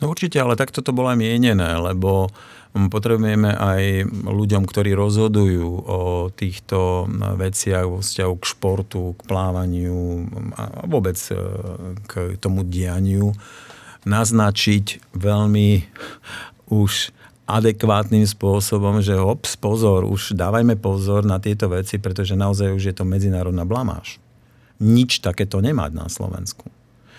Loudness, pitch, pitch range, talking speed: -20 LUFS, 100 Hz, 95-110 Hz, 120 wpm